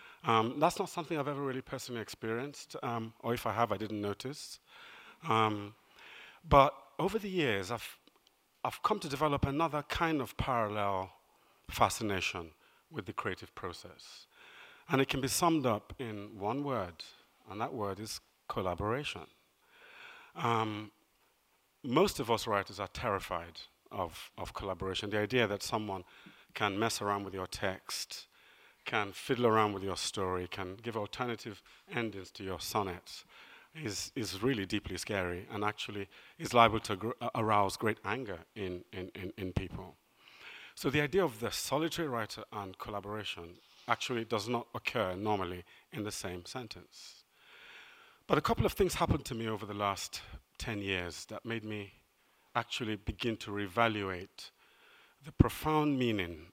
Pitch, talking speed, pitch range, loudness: 110 Hz, 150 wpm, 100-130 Hz, -35 LUFS